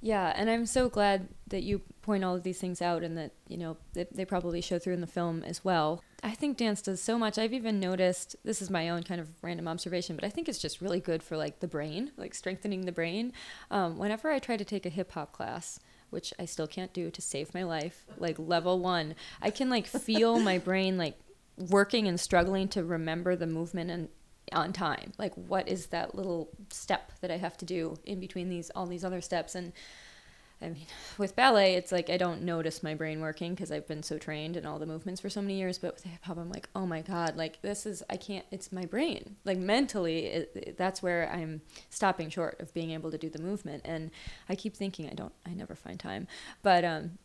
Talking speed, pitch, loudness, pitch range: 240 wpm, 180 Hz, -33 LUFS, 165-200 Hz